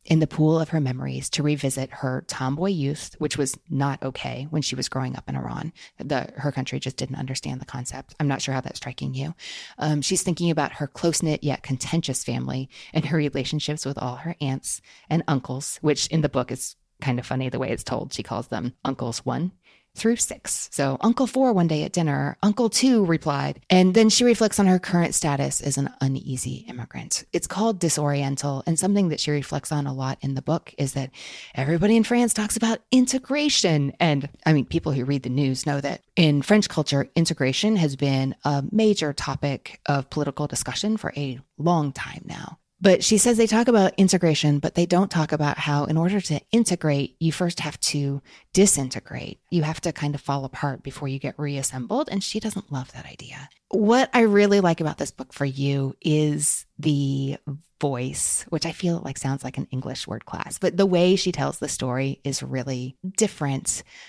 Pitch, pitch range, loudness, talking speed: 150 Hz, 135-175 Hz, -23 LUFS, 205 wpm